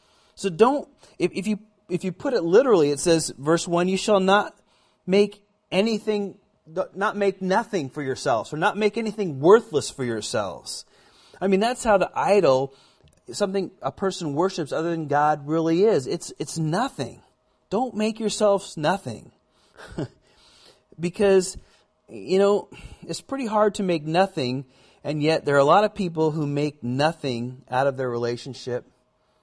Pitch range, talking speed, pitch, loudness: 150-205 Hz, 155 wpm, 180 Hz, -23 LUFS